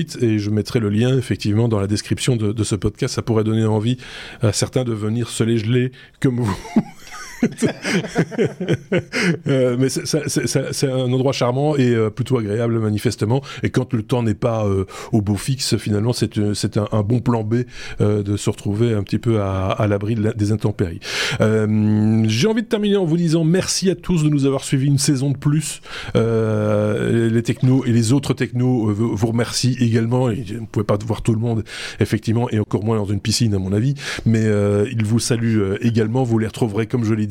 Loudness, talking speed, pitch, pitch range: -19 LUFS, 215 wpm, 115 Hz, 110-130 Hz